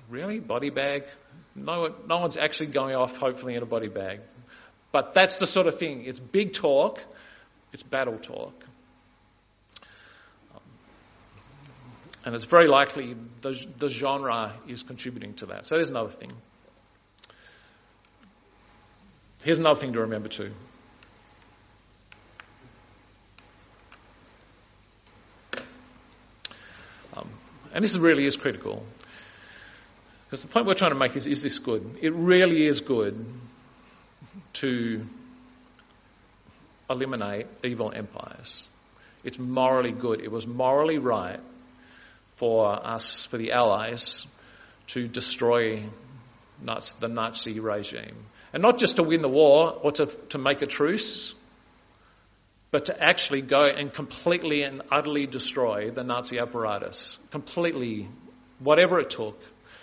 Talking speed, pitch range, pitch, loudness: 120 wpm, 115-145 Hz, 125 Hz, -26 LUFS